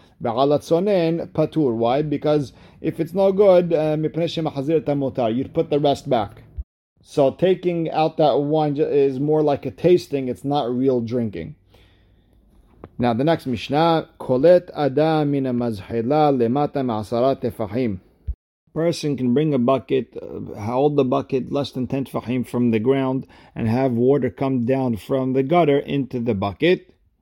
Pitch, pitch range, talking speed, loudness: 135 Hz, 120-155 Hz, 125 wpm, -20 LUFS